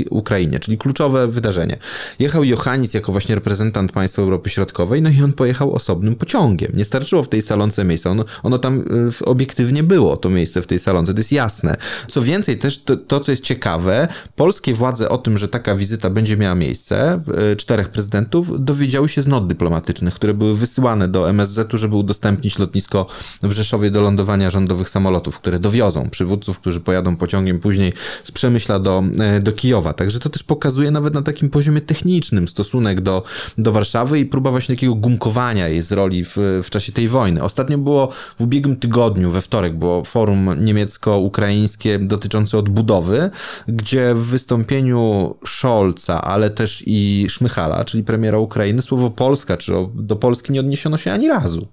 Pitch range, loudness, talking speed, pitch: 95-130 Hz, -17 LUFS, 170 wpm, 110 Hz